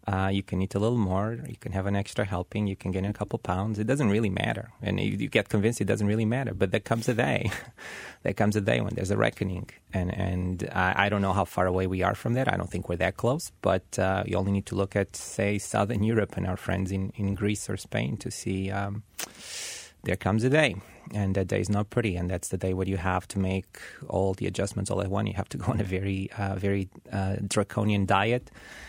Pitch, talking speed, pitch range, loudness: 100 Hz, 255 wpm, 95-110 Hz, -28 LUFS